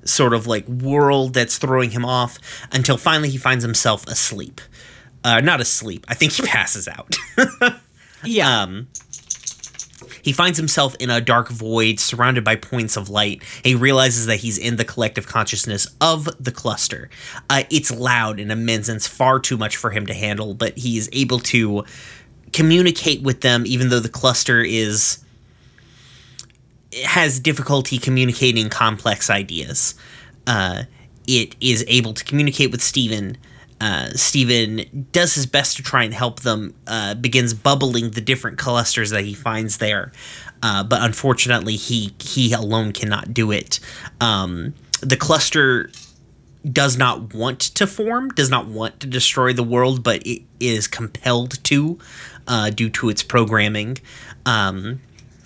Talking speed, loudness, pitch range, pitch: 155 wpm, -18 LUFS, 110-130 Hz, 120 Hz